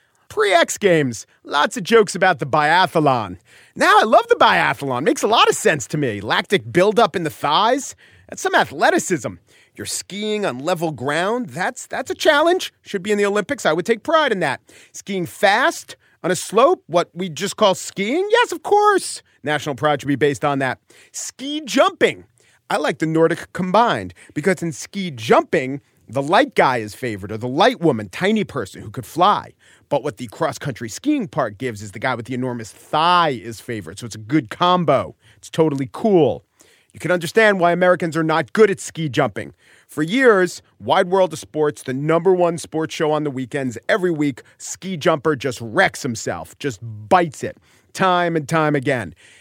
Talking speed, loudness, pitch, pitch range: 190 wpm, -19 LUFS, 170 Hz, 140-205 Hz